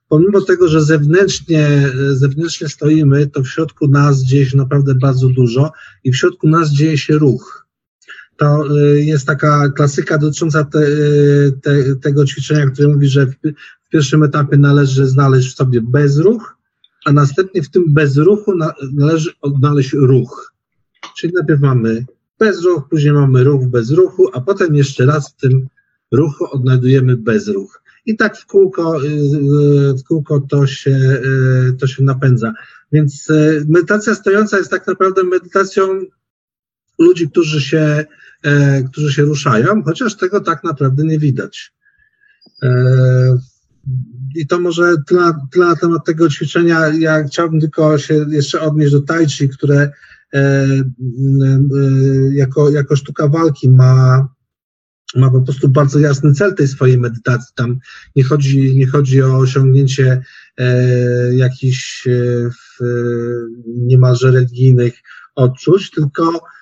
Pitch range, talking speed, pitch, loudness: 135-160 Hz, 130 wpm, 145 Hz, -13 LUFS